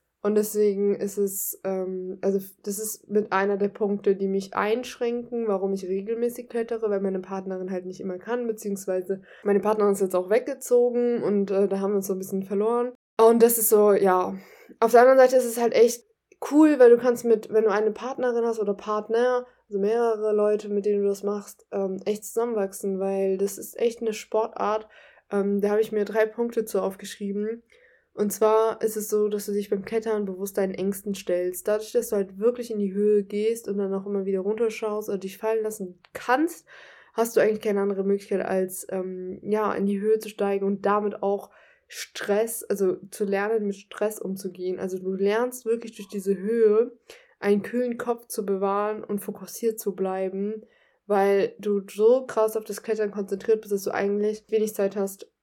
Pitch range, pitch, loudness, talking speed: 200-225 Hz, 210 Hz, -25 LUFS, 200 wpm